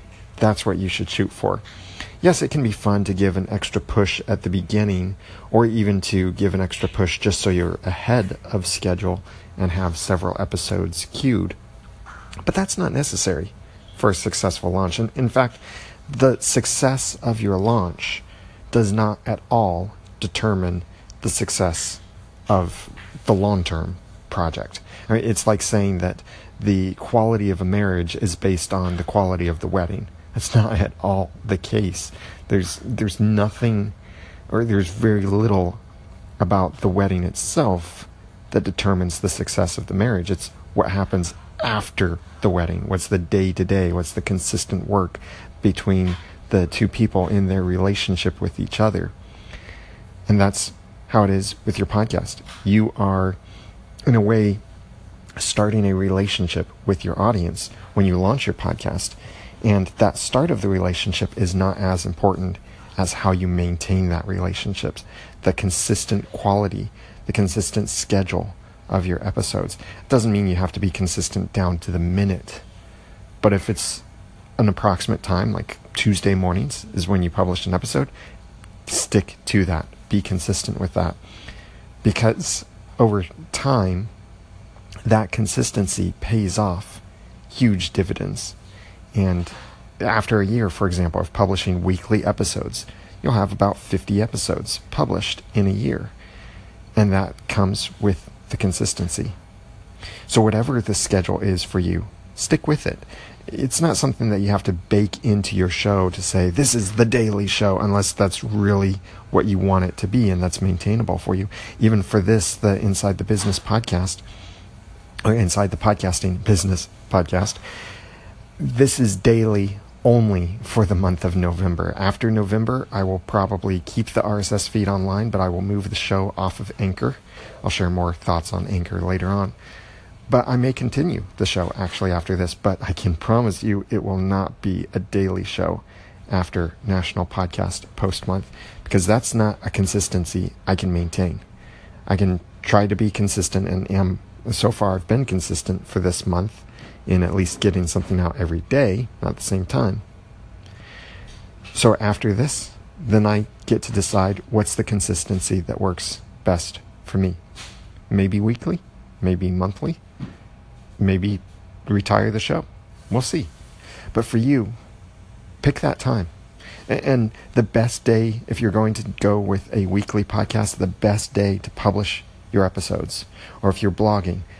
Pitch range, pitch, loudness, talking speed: 95-105 Hz, 100 Hz, -21 LUFS, 155 wpm